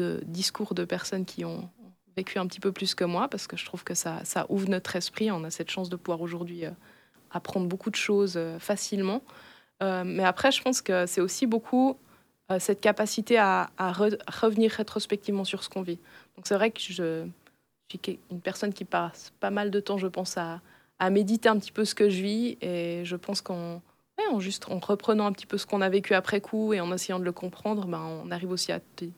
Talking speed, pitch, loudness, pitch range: 235 wpm, 195 Hz, -29 LUFS, 180-210 Hz